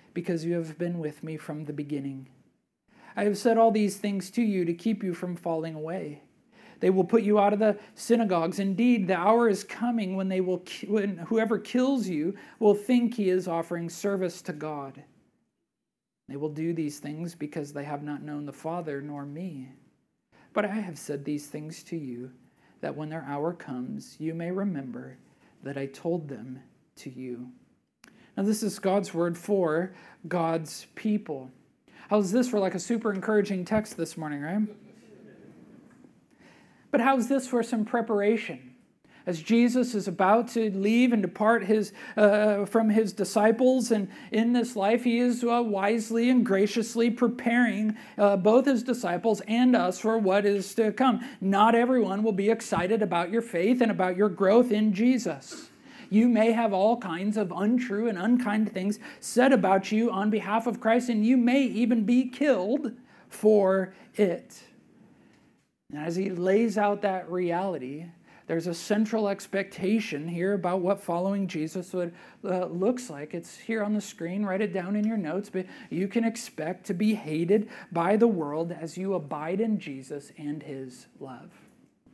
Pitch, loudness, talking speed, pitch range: 200 Hz, -27 LUFS, 170 wpm, 170-225 Hz